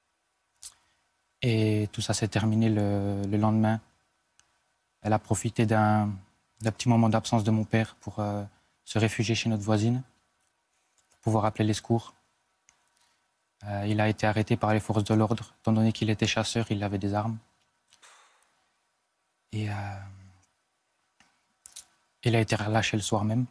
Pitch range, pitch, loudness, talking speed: 105-115 Hz, 110 Hz, -27 LUFS, 150 wpm